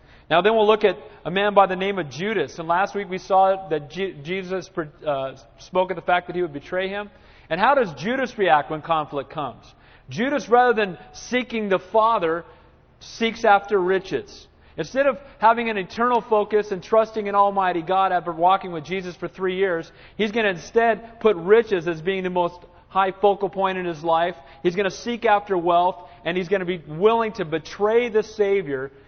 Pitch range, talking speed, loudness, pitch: 175-215 Hz, 200 wpm, -22 LUFS, 190 Hz